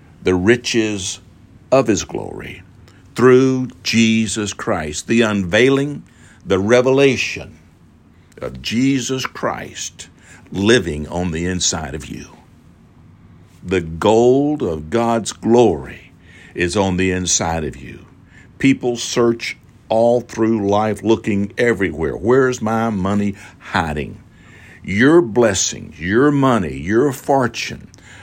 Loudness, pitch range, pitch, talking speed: -17 LUFS, 90-120 Hz, 110 Hz, 105 wpm